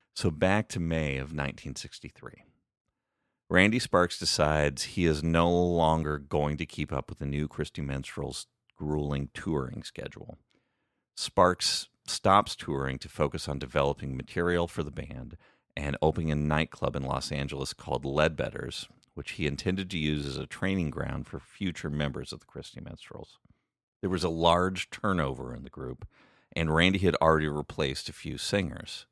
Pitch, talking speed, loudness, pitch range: 75 Hz, 160 wpm, -29 LUFS, 70-85 Hz